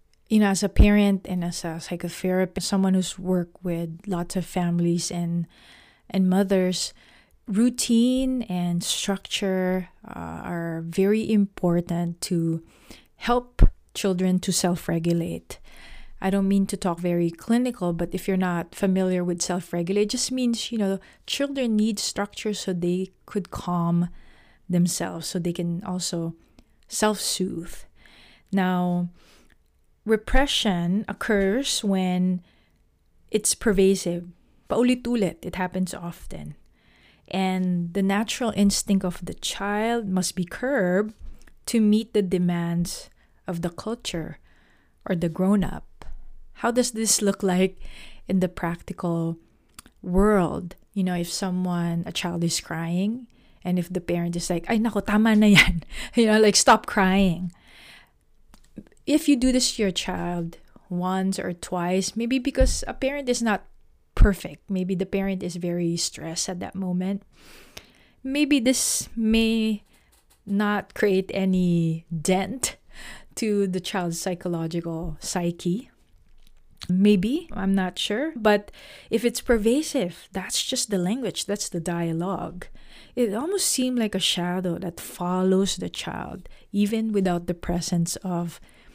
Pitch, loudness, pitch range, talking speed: 185 Hz, -24 LUFS, 175-210 Hz, 130 wpm